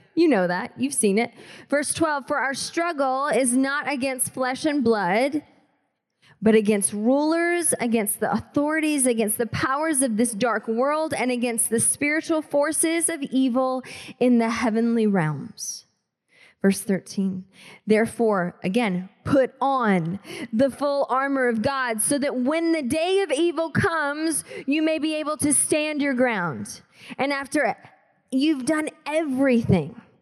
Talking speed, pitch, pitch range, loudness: 145 wpm, 265 Hz, 230-300 Hz, -23 LUFS